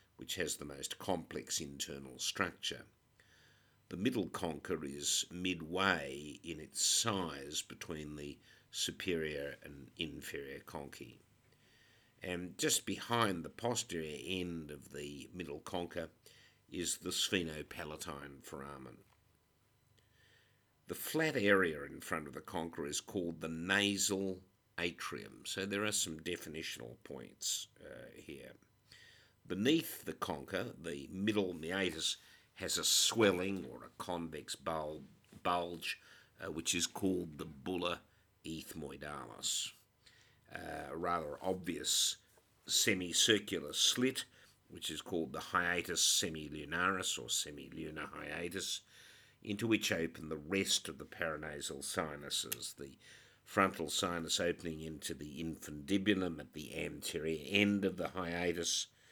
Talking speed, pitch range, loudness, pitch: 115 wpm, 80-100 Hz, -37 LUFS, 90 Hz